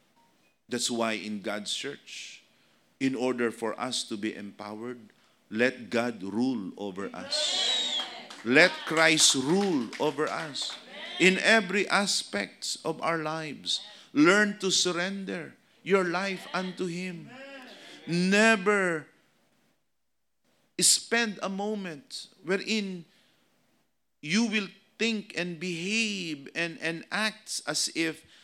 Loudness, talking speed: -27 LUFS, 105 wpm